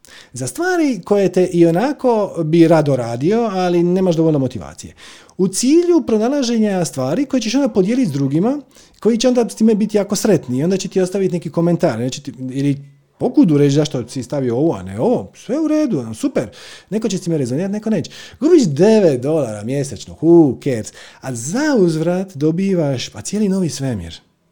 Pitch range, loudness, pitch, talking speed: 140-225 Hz, -16 LUFS, 180 Hz, 180 wpm